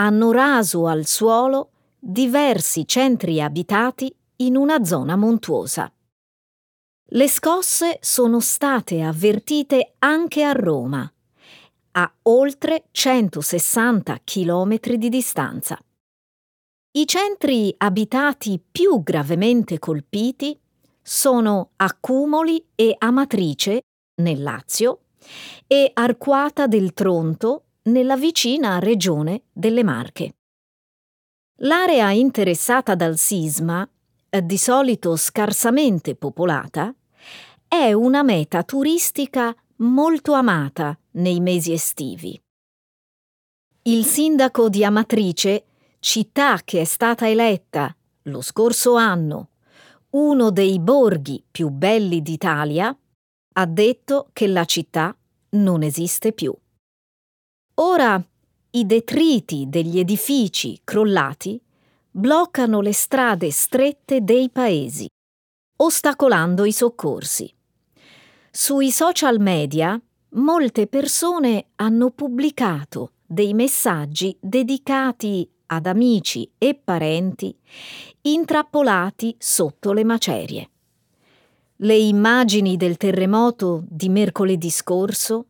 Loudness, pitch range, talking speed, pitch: -19 LUFS, 180-265 Hz, 90 wpm, 220 Hz